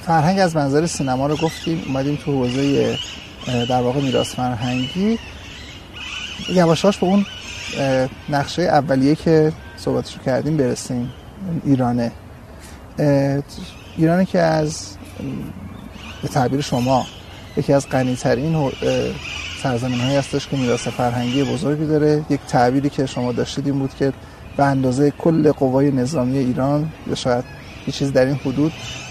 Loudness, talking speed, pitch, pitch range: -19 LUFS, 130 wpm, 135 Hz, 125-150 Hz